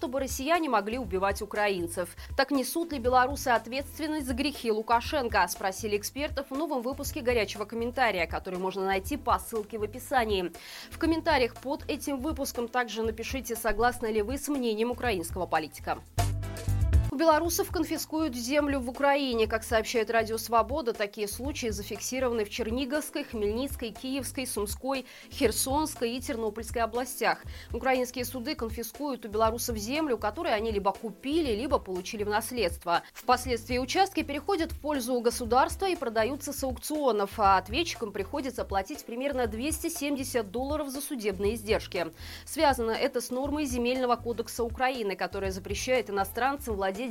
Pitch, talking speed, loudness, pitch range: 245 Hz, 140 wpm, -30 LUFS, 220-280 Hz